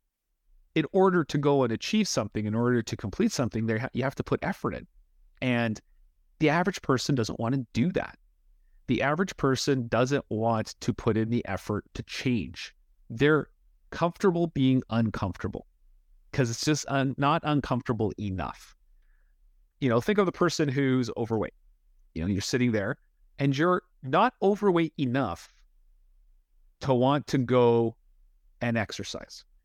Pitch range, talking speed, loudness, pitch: 110-145 Hz, 150 wpm, -27 LUFS, 125 Hz